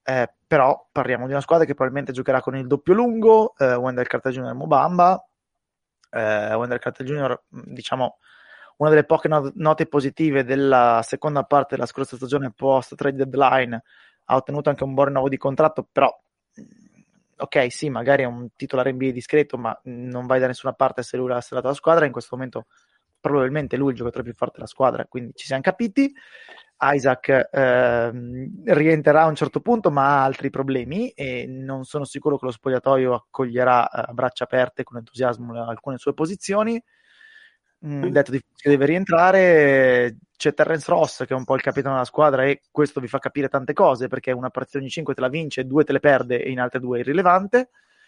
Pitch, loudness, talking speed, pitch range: 135 Hz, -21 LUFS, 190 wpm, 130-150 Hz